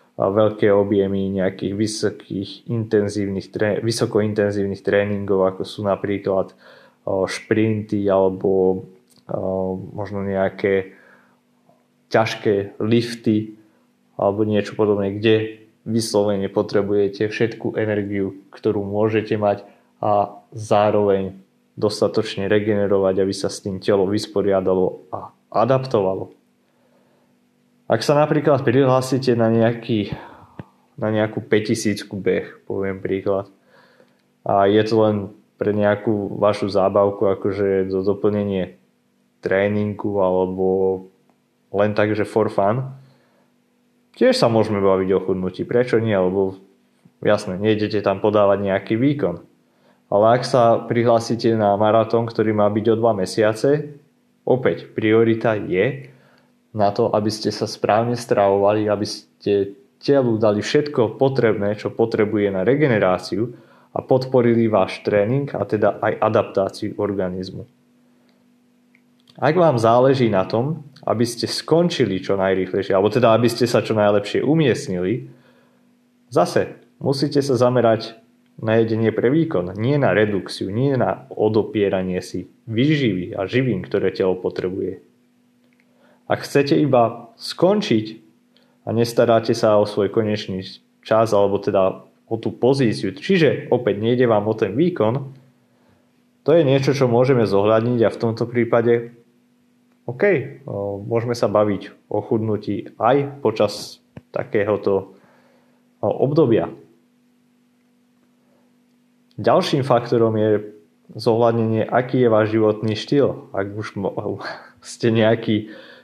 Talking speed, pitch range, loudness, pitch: 115 wpm, 100-120 Hz, -20 LUFS, 110 Hz